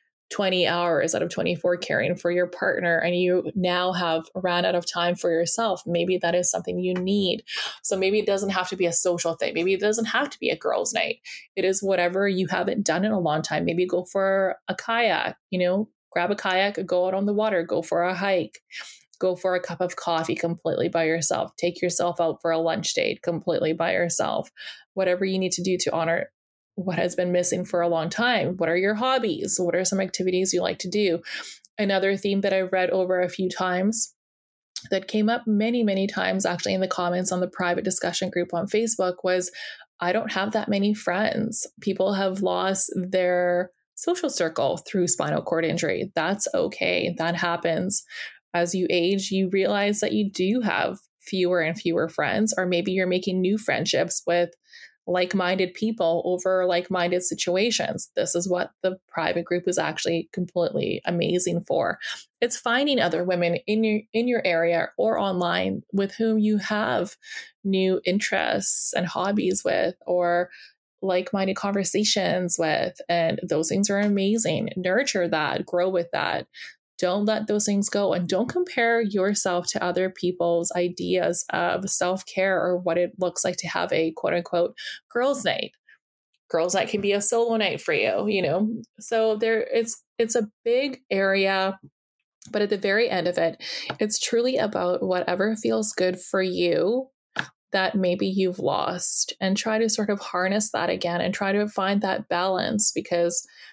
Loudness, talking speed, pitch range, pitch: -24 LUFS, 180 wpm, 175-210 Hz, 185 Hz